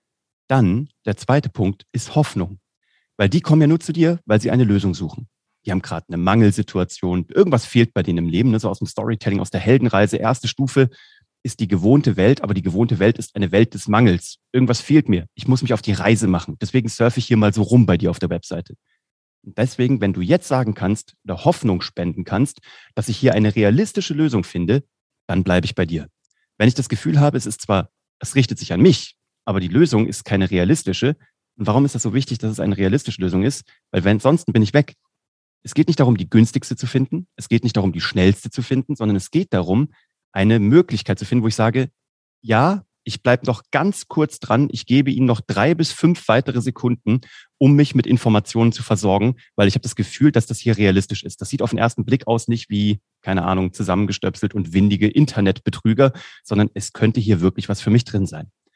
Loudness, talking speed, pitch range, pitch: -18 LUFS, 225 wpm, 100-130 Hz, 115 Hz